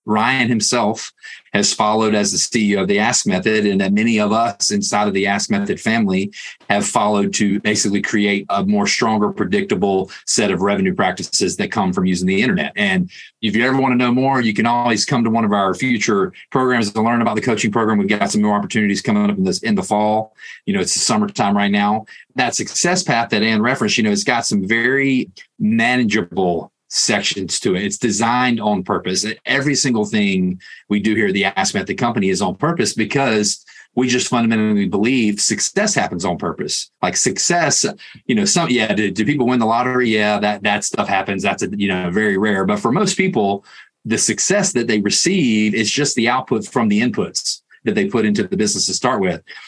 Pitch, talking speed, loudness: 115 Hz, 215 wpm, -17 LUFS